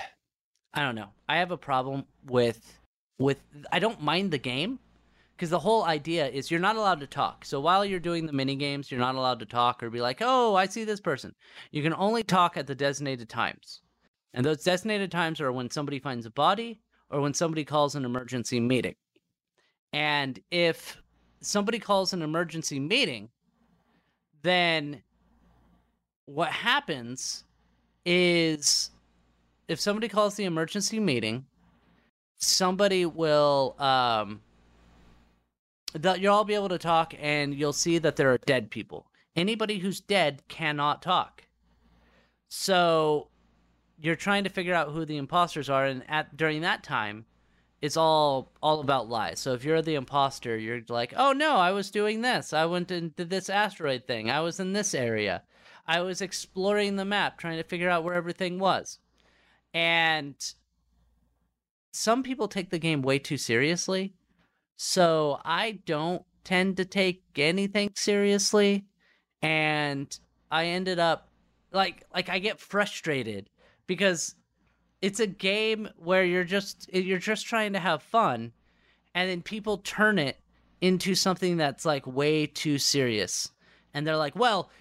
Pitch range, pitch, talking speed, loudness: 135-190 Hz, 160 Hz, 155 wpm, -27 LUFS